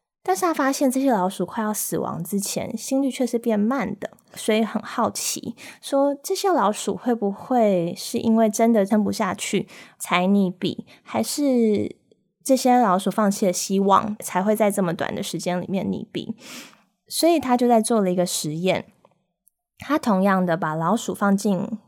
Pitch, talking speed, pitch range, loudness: 215 Hz, 250 characters per minute, 190-245 Hz, -22 LUFS